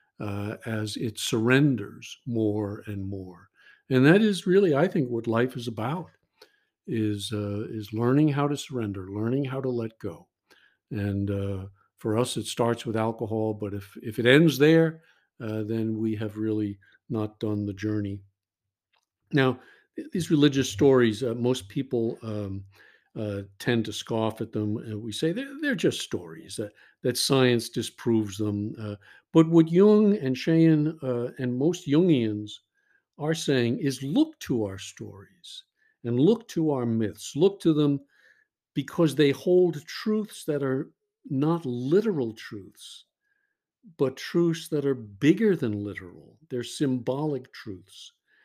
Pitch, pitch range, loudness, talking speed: 125 Hz, 110-160 Hz, -26 LUFS, 150 wpm